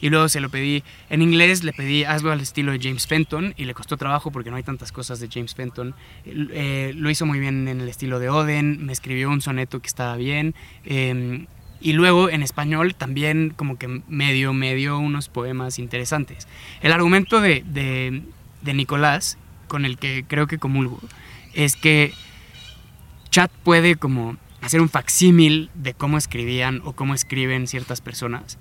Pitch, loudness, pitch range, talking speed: 140 Hz, -20 LUFS, 130-155 Hz, 180 wpm